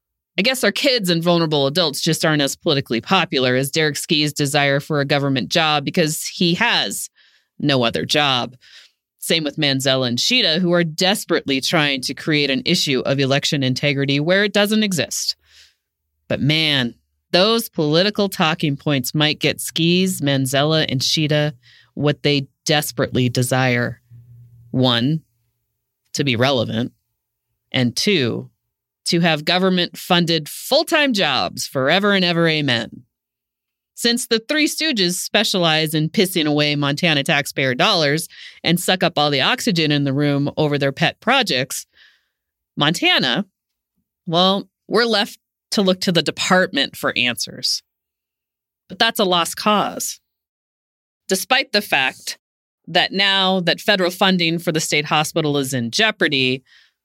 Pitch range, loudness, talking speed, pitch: 135-185 Hz, -18 LUFS, 140 wpm, 155 Hz